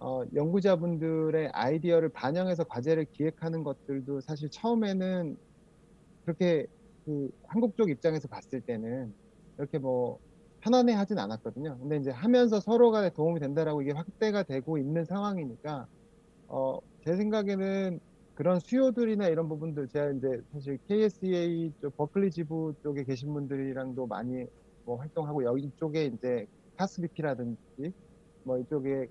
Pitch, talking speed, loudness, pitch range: 155 Hz, 330 characters per minute, -31 LUFS, 135-185 Hz